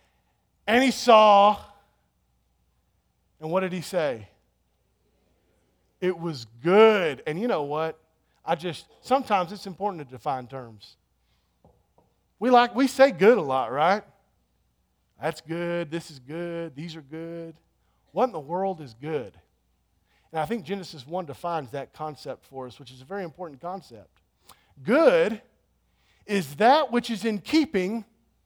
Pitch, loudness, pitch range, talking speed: 165 Hz, -24 LUFS, 125-200 Hz, 145 wpm